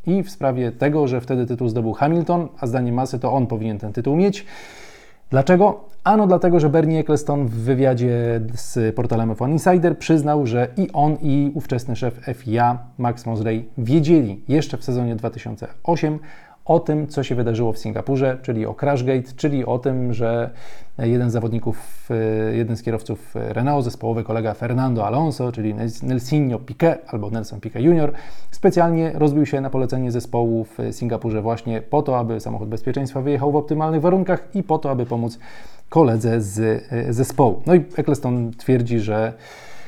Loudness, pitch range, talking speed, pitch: -20 LUFS, 115-150 Hz, 160 wpm, 125 Hz